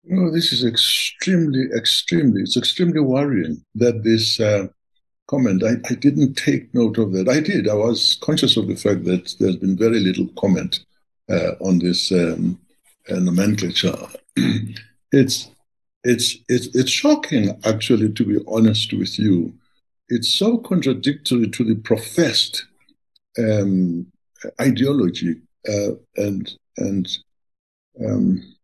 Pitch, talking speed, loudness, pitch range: 115 Hz, 130 wpm, -19 LUFS, 100-130 Hz